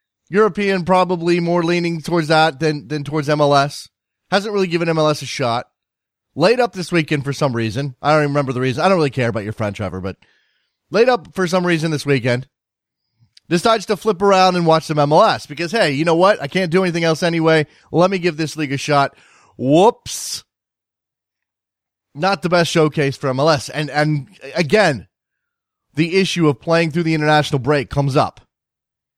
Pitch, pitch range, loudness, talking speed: 155 Hz, 140-175 Hz, -17 LUFS, 190 wpm